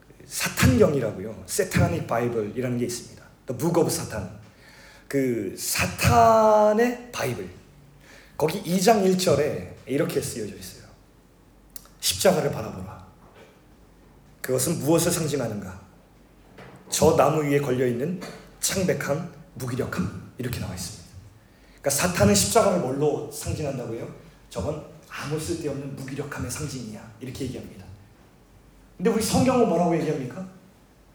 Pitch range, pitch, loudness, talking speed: 110-165 Hz, 140 Hz, -24 LUFS, 295 characters per minute